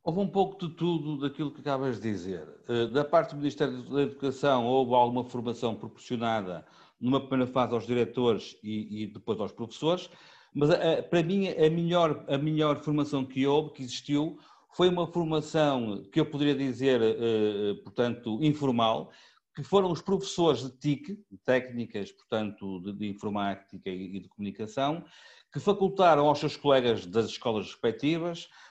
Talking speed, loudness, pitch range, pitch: 165 wpm, -29 LUFS, 115-155 Hz, 135 Hz